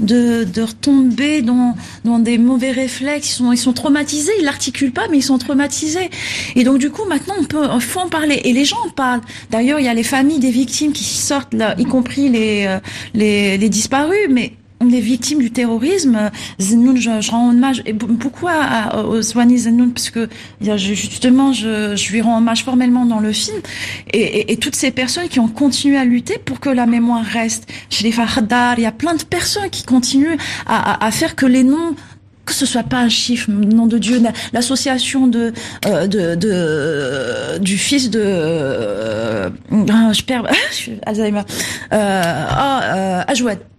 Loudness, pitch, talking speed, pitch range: -15 LUFS, 245 Hz, 190 wpm, 220-275 Hz